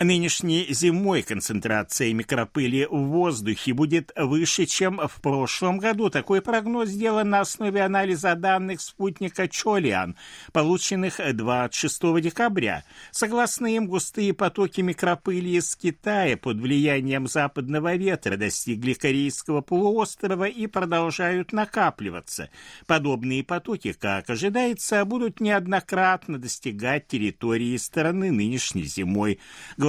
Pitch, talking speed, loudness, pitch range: 170 Hz, 105 wpm, -24 LUFS, 135-195 Hz